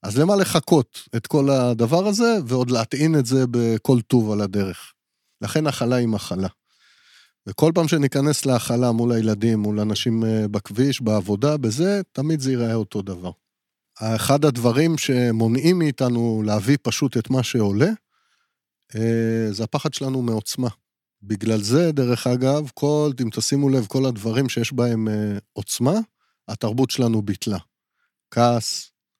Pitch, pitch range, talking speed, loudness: 120 Hz, 110-140 Hz, 135 wpm, -21 LUFS